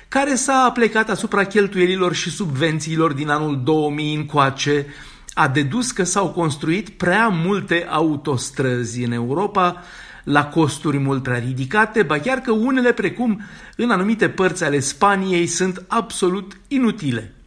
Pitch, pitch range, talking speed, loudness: 175 Hz, 150-205 Hz, 135 wpm, -19 LUFS